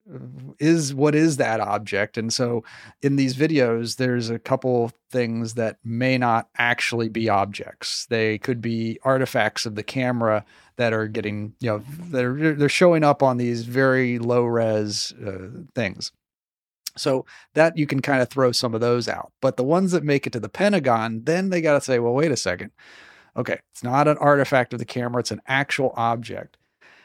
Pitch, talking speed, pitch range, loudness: 125 Hz, 185 wpm, 115-140 Hz, -22 LUFS